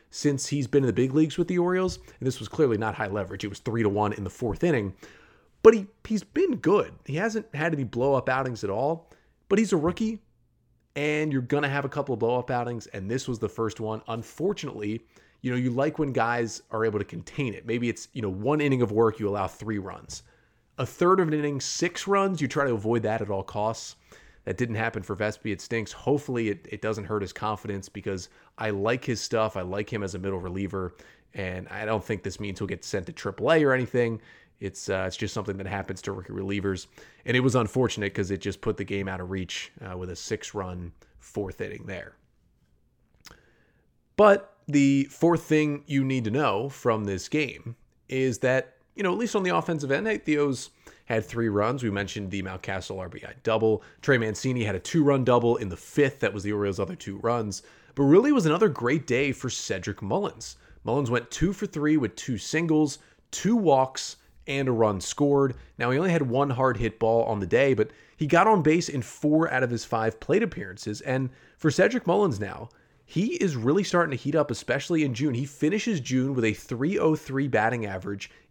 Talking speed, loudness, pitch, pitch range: 220 wpm, -26 LUFS, 120 Hz, 105-145 Hz